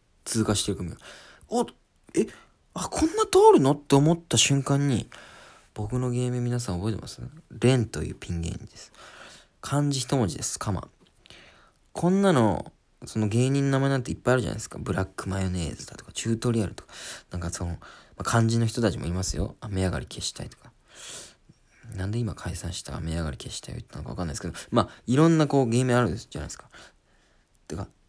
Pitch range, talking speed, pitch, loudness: 95-135 Hz, 395 characters per minute, 115 Hz, -26 LUFS